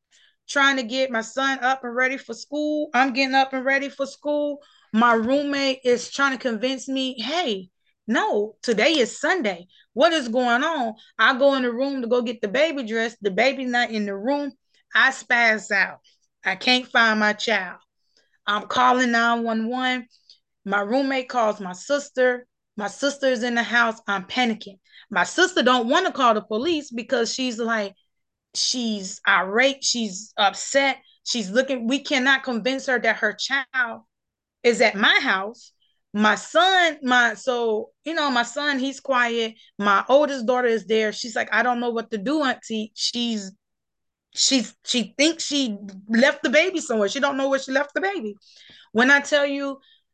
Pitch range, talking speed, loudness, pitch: 225-275 Hz, 175 wpm, -21 LUFS, 250 Hz